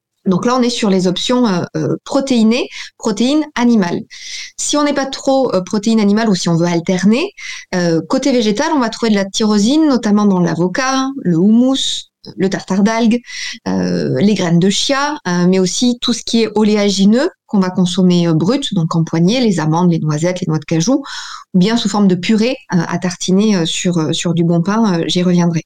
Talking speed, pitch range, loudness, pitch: 210 wpm, 175-245 Hz, -14 LUFS, 205 Hz